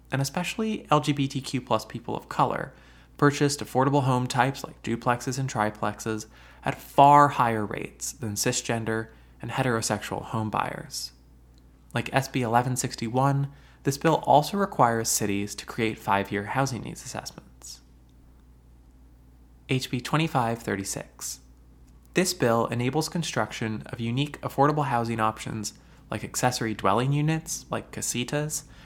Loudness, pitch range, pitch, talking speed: -26 LUFS, 100-135 Hz, 120 Hz, 120 wpm